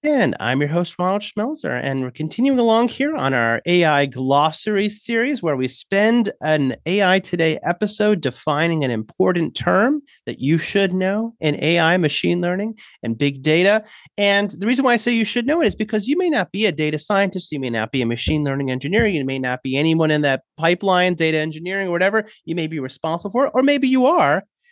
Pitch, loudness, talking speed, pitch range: 180 Hz, -19 LUFS, 210 wpm, 150-215 Hz